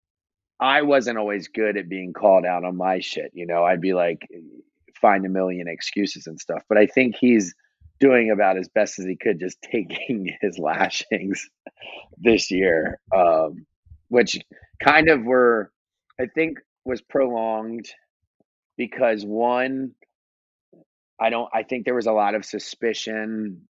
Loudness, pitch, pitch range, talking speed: -22 LUFS, 105 Hz, 95-120 Hz, 150 wpm